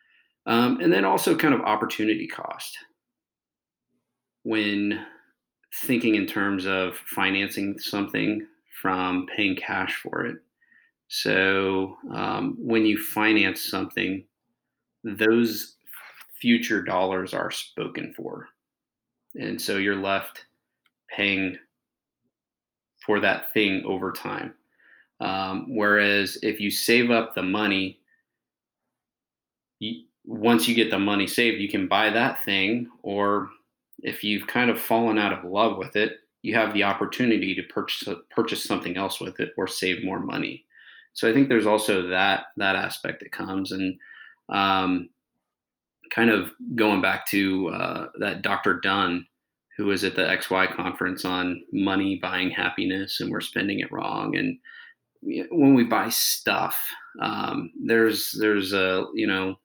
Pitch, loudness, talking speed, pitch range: 100 Hz, -24 LUFS, 135 wpm, 95-115 Hz